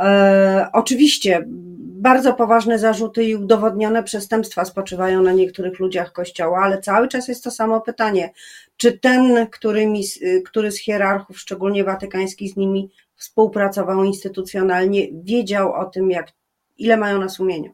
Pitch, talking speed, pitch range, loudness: 200 Hz, 130 wpm, 190-225 Hz, -18 LUFS